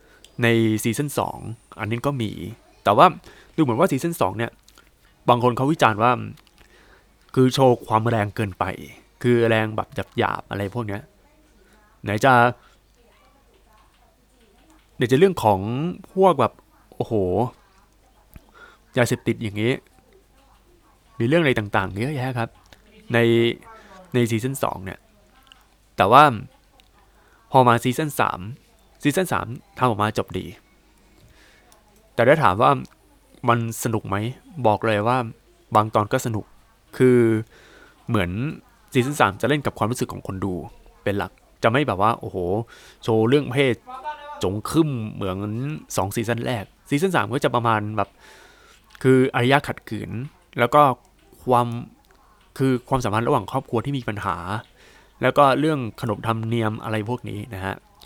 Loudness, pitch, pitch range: -21 LUFS, 120 Hz, 110-130 Hz